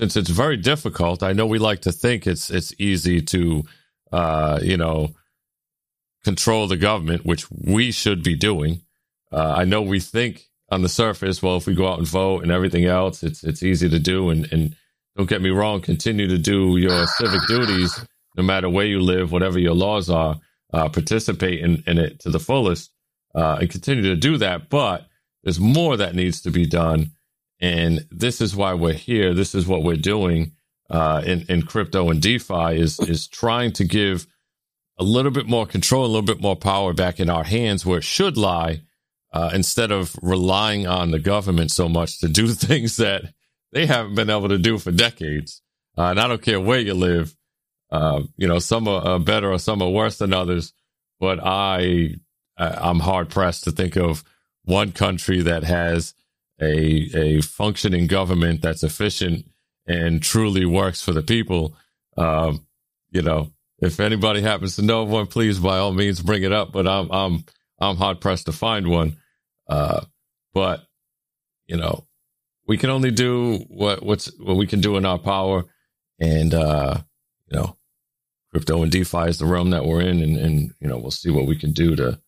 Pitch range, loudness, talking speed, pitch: 85-105 Hz, -20 LUFS, 190 wpm, 90 Hz